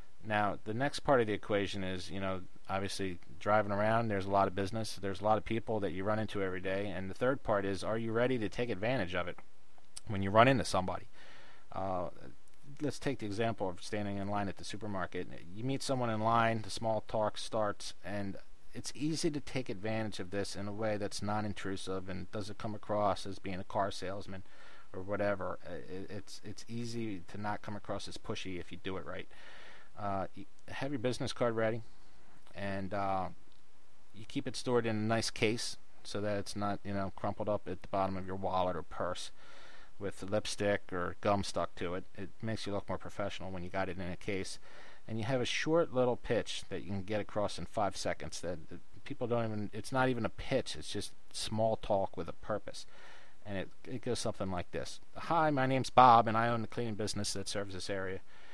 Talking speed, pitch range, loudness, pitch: 215 wpm, 95-115 Hz, -36 LUFS, 100 Hz